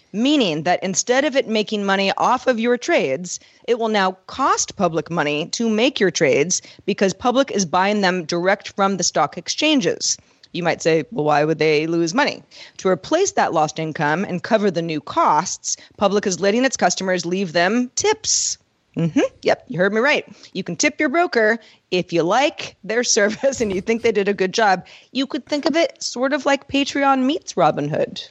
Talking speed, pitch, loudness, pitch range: 200 wpm, 205 Hz, -19 LUFS, 180-260 Hz